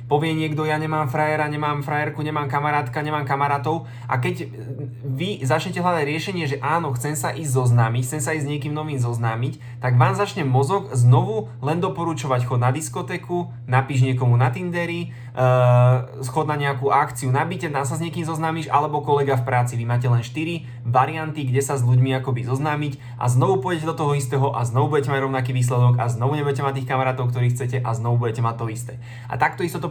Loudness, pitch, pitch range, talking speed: -22 LUFS, 135 Hz, 125-150 Hz, 200 wpm